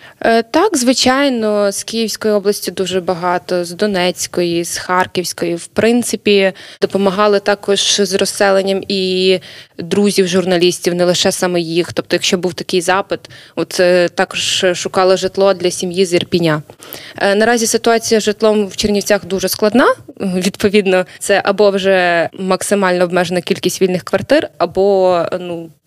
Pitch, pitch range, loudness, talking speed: 190 Hz, 180-205 Hz, -14 LUFS, 130 wpm